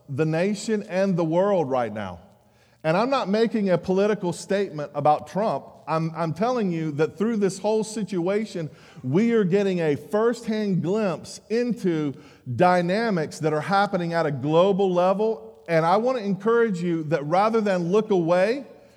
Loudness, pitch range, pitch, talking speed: -23 LUFS, 160-210 Hz, 185 Hz, 160 wpm